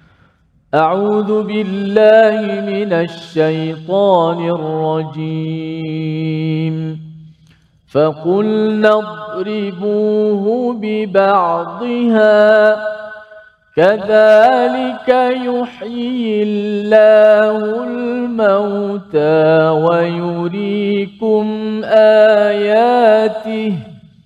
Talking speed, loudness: 35 wpm, -13 LUFS